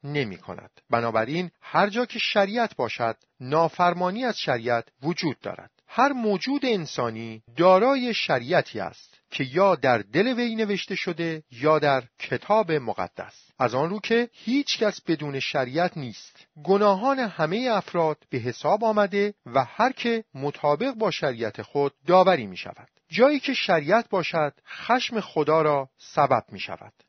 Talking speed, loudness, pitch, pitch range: 145 wpm, -24 LUFS, 175 Hz, 145-220 Hz